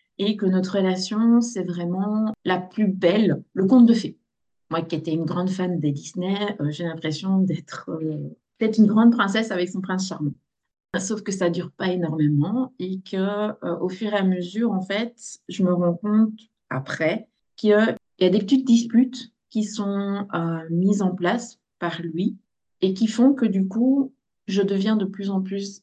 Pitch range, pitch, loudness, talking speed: 180-220 Hz, 195 Hz, -23 LUFS, 195 wpm